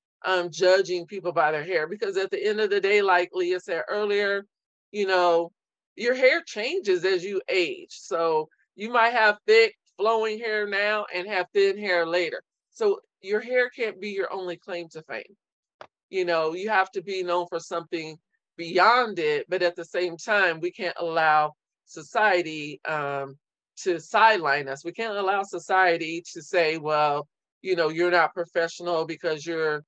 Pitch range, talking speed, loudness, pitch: 170-225 Hz, 175 wpm, -25 LUFS, 185 Hz